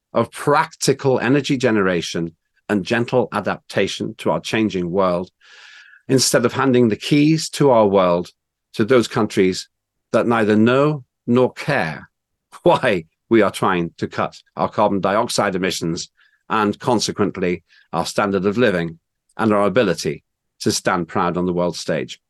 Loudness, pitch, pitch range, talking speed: -19 LUFS, 105 Hz, 90-125 Hz, 145 wpm